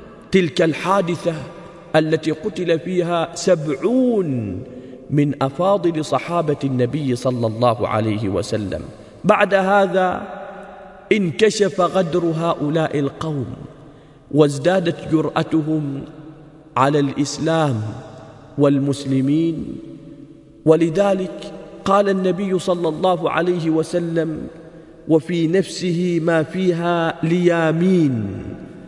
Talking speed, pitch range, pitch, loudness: 75 wpm, 145-180 Hz, 160 Hz, -19 LUFS